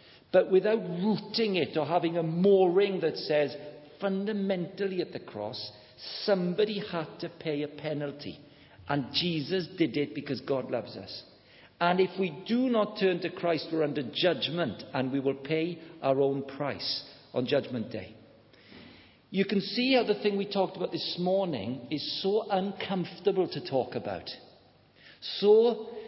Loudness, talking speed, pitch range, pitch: -29 LUFS, 155 wpm, 145-195 Hz, 170 Hz